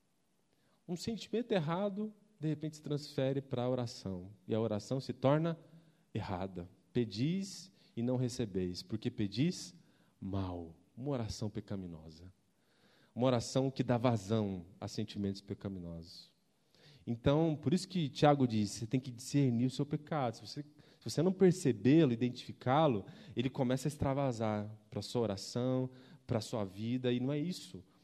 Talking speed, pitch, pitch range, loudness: 150 wpm, 125 Hz, 105-150 Hz, -36 LUFS